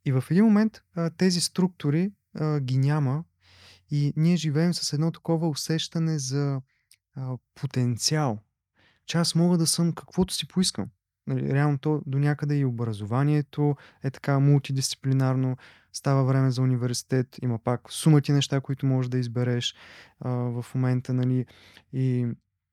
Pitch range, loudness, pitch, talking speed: 125-155 Hz, -26 LUFS, 135 Hz, 145 wpm